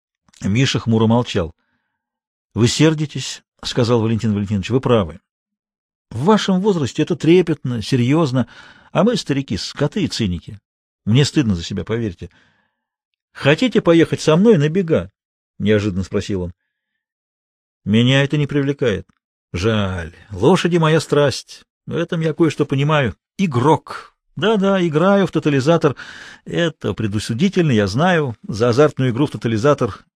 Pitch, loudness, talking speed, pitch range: 140 Hz, -17 LUFS, 125 wpm, 110-160 Hz